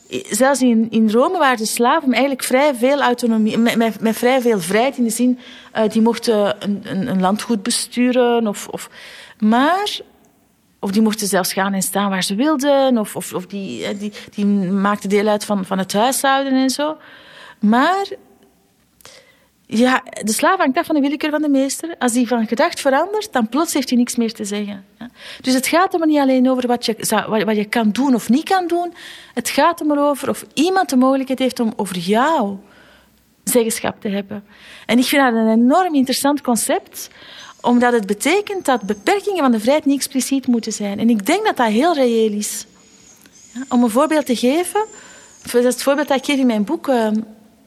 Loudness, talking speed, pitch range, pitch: -17 LUFS, 195 wpm, 220-280 Hz, 245 Hz